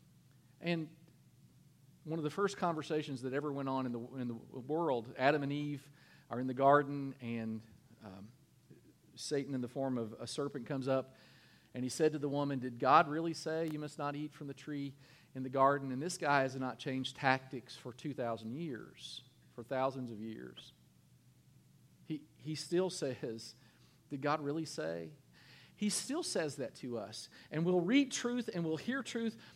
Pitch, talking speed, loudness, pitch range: 140 Hz, 180 wpm, -37 LUFS, 125-155 Hz